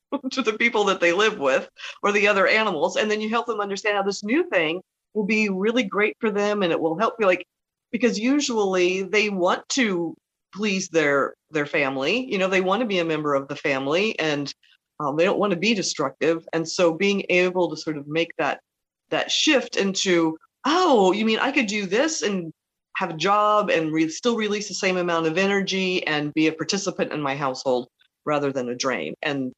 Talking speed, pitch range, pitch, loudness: 215 wpm, 160-215 Hz, 190 Hz, -22 LUFS